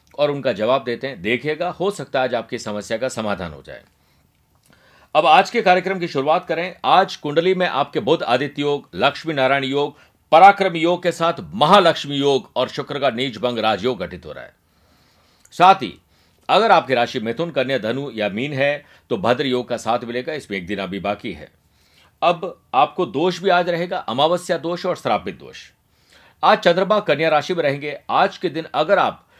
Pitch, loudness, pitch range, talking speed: 145 Hz, -19 LUFS, 125-175 Hz, 190 wpm